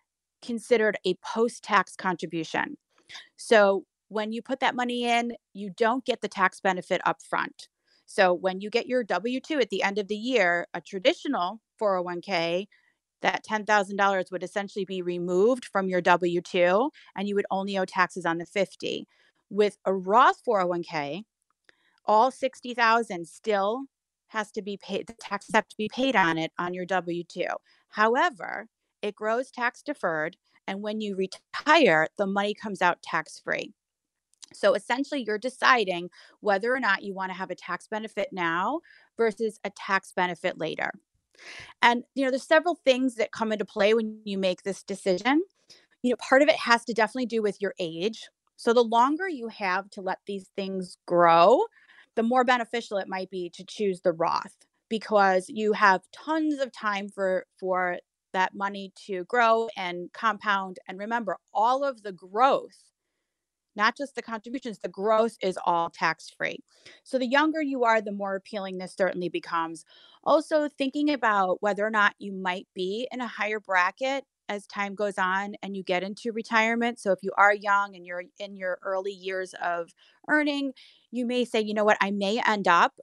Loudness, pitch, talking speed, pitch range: -26 LUFS, 205 Hz, 175 wpm, 185-240 Hz